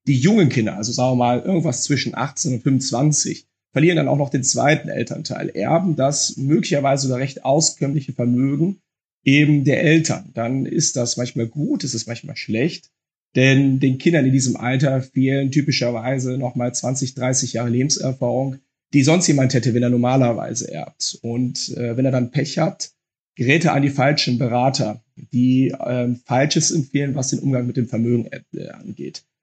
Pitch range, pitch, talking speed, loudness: 125-145 Hz, 135 Hz, 175 wpm, -19 LUFS